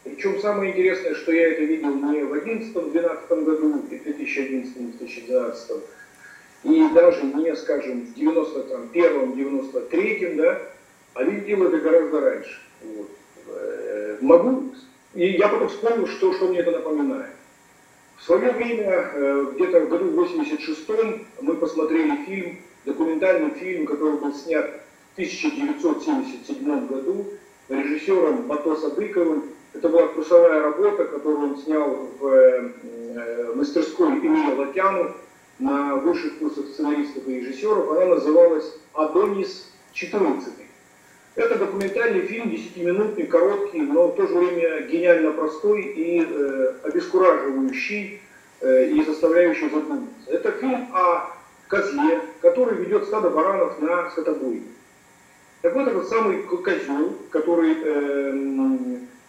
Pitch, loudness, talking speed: 210 Hz, -22 LUFS, 115 wpm